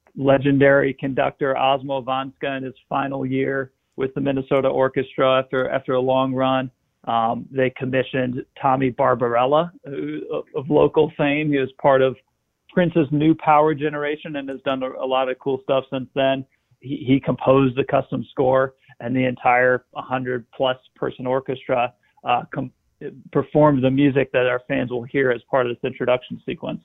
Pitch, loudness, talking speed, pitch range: 135 Hz, -21 LUFS, 165 wpm, 130-140 Hz